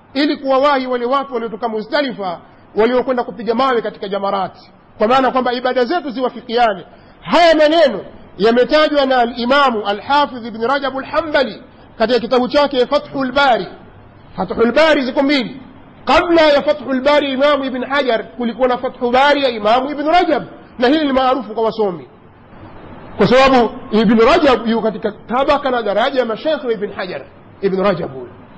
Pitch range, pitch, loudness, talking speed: 220-280 Hz, 250 Hz, -15 LUFS, 115 wpm